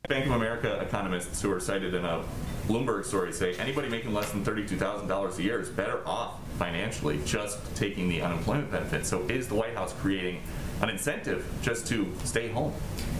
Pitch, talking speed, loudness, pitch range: 100 Hz, 180 wpm, -31 LUFS, 90-115 Hz